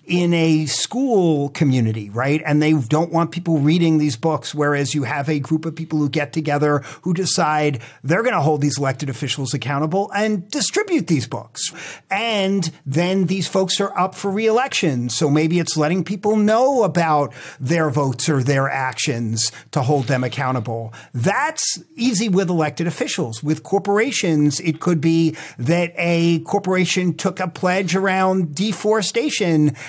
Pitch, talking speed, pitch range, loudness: 160 Hz, 160 wpm, 145-185 Hz, -19 LUFS